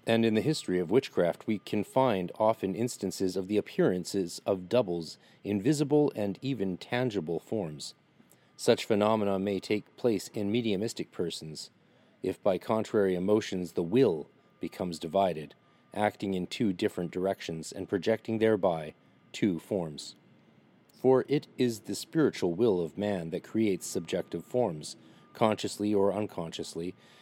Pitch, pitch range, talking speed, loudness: 105 Hz, 95-110 Hz, 135 wpm, -30 LUFS